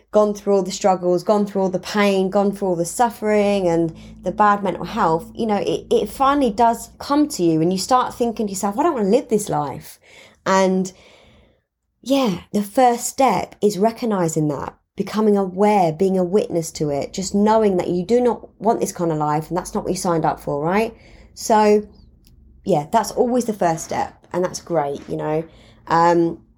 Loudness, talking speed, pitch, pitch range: -19 LUFS, 205 wpm, 195 Hz, 170-220 Hz